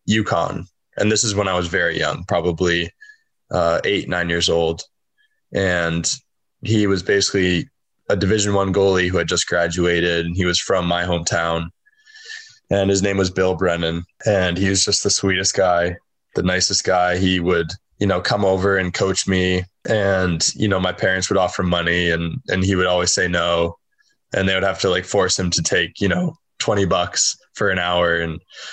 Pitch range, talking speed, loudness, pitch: 85-100 Hz, 190 wpm, -19 LUFS, 90 Hz